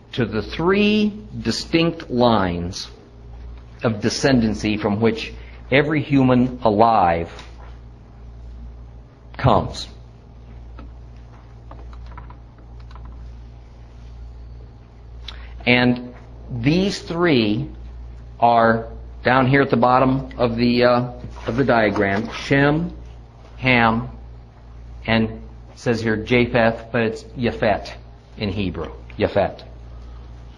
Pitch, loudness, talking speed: 100 Hz, -19 LUFS, 80 wpm